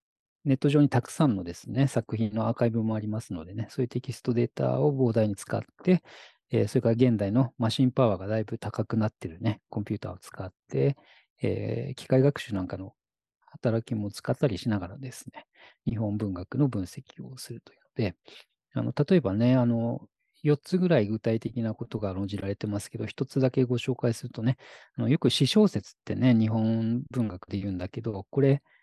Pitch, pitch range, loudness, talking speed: 115 Hz, 105-130 Hz, -28 LUFS, 385 characters per minute